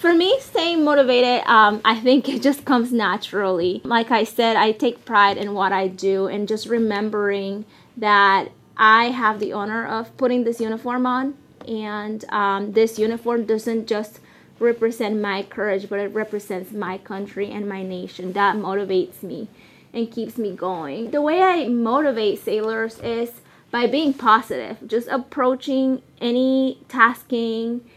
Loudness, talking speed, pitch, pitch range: -20 LUFS, 150 wpm, 225 Hz, 205-245 Hz